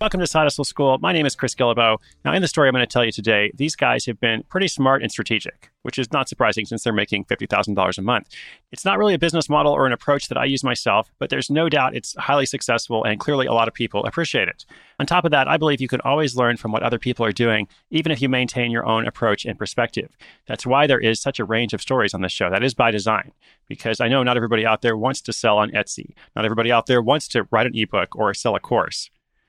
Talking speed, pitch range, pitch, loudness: 265 wpm, 110-140 Hz, 120 Hz, -20 LUFS